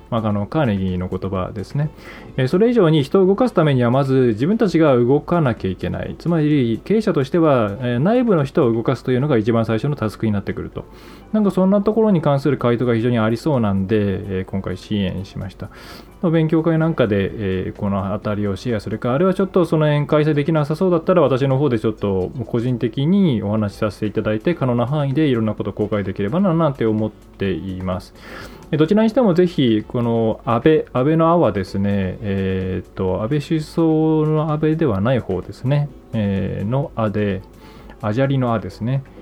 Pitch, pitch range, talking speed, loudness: 120 Hz, 105-155 Hz, 400 characters per minute, -19 LUFS